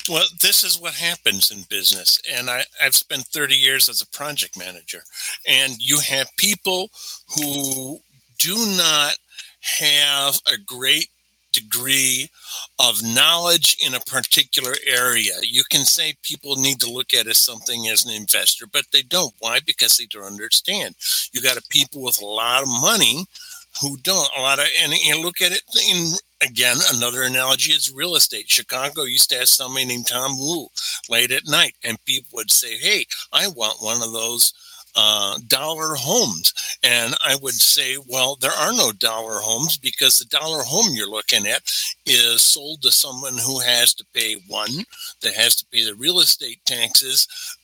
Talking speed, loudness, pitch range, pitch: 175 wpm, -17 LUFS, 125-165 Hz, 140 Hz